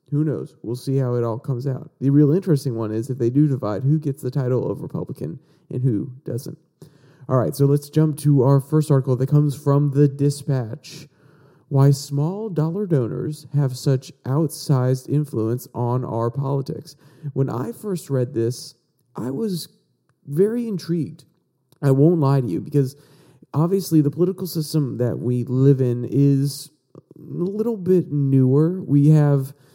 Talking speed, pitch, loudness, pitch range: 165 wpm, 145 Hz, -21 LUFS, 130-155 Hz